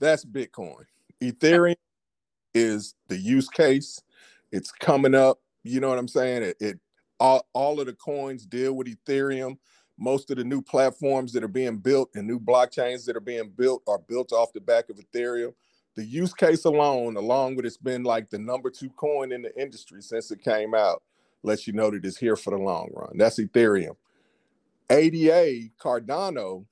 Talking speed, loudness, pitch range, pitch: 185 wpm, -25 LUFS, 115-140 Hz, 130 Hz